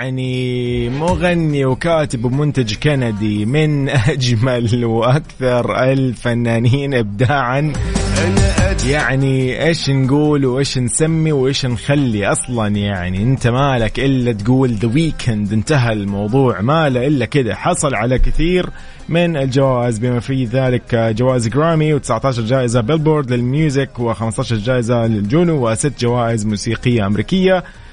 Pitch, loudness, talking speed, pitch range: 130 Hz, -16 LUFS, 110 wpm, 115-145 Hz